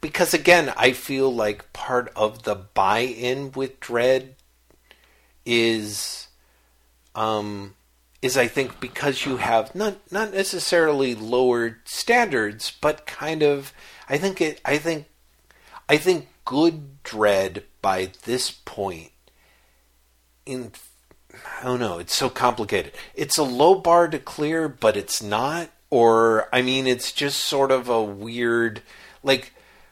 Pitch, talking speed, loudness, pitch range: 125 Hz, 130 wpm, -22 LUFS, 105-145 Hz